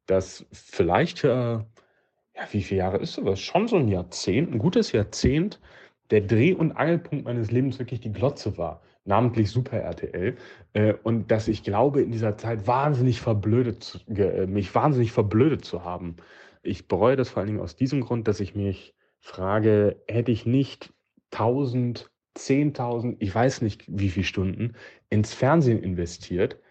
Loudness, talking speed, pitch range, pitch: -25 LUFS, 160 wpm, 100-125 Hz, 115 Hz